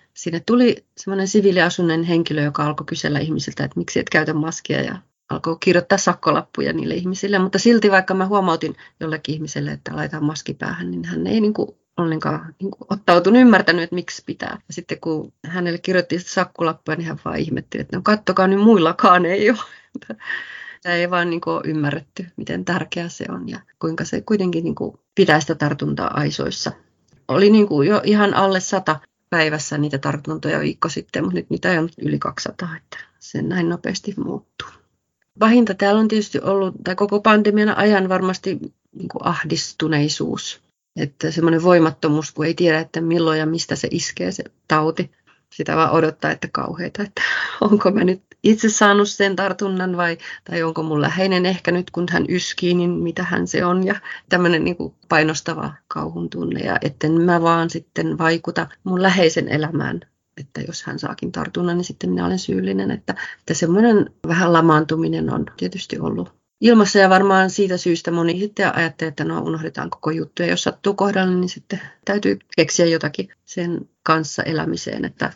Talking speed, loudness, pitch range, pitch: 170 wpm, -19 LUFS, 155-195 Hz, 175 Hz